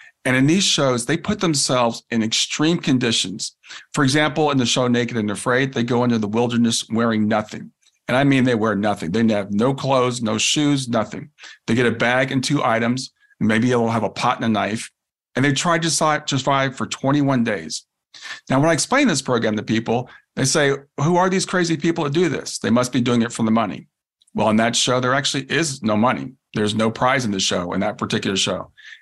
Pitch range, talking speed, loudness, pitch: 115-145 Hz, 220 wpm, -19 LUFS, 125 Hz